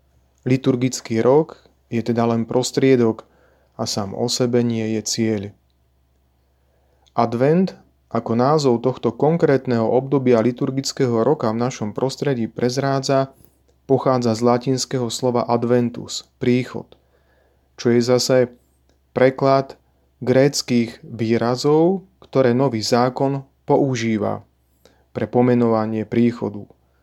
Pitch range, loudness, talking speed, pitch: 110-130 Hz, -19 LUFS, 95 wpm, 120 Hz